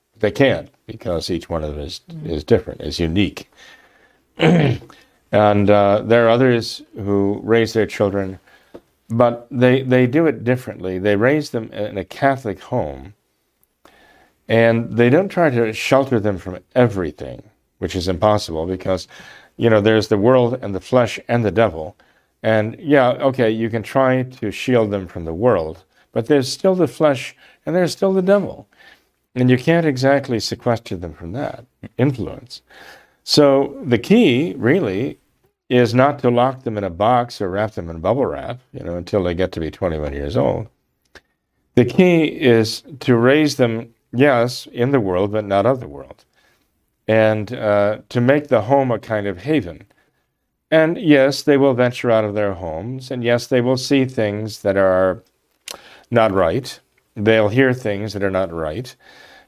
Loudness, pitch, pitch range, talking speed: -18 LUFS, 115 Hz, 100-130 Hz, 170 wpm